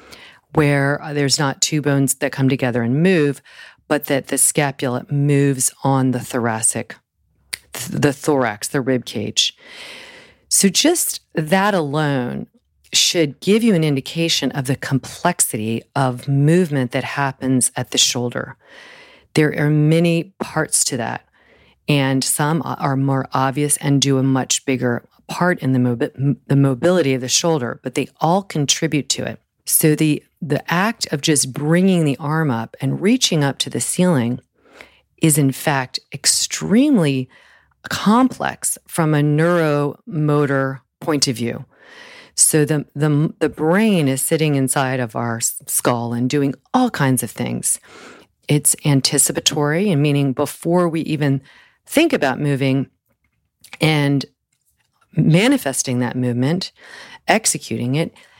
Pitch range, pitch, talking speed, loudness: 130-165 Hz, 145 Hz, 135 wpm, -18 LUFS